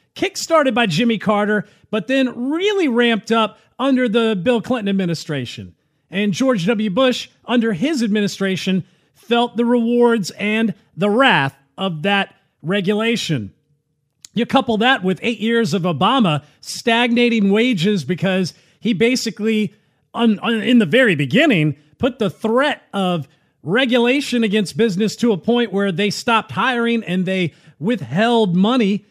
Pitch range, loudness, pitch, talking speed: 185-240 Hz, -18 LUFS, 215 Hz, 135 wpm